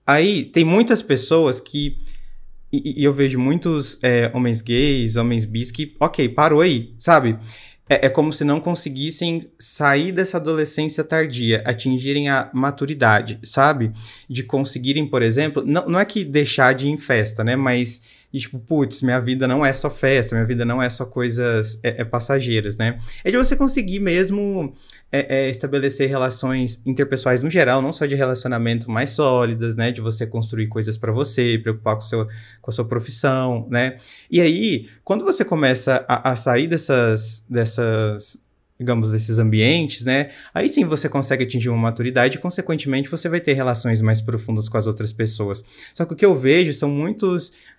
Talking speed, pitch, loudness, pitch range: 180 wpm, 130 Hz, -19 LUFS, 115-145 Hz